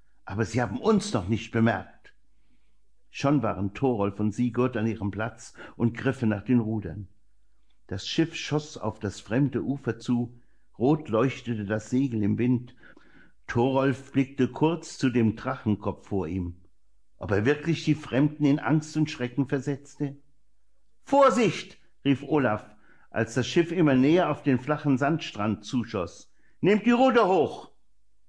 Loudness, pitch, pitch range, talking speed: -26 LUFS, 125 Hz, 110-145 Hz, 145 wpm